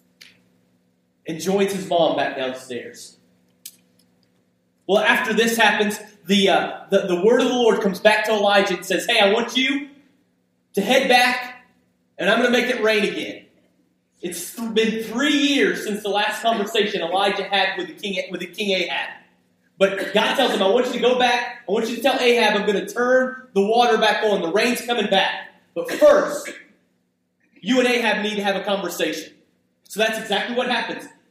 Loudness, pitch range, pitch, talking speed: -19 LUFS, 175-240 Hz, 210 Hz, 190 wpm